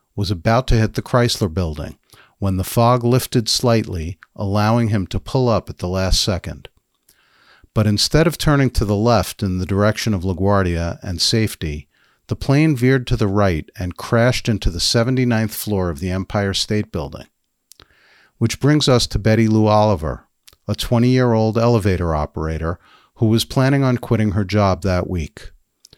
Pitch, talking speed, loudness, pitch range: 105 Hz, 170 wpm, -18 LUFS, 95-120 Hz